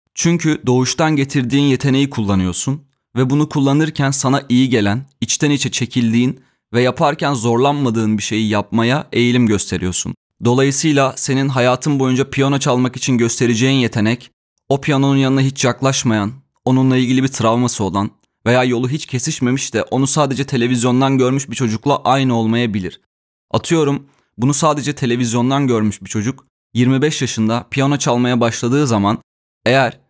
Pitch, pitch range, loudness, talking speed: 130 Hz, 120-140 Hz, -16 LUFS, 135 wpm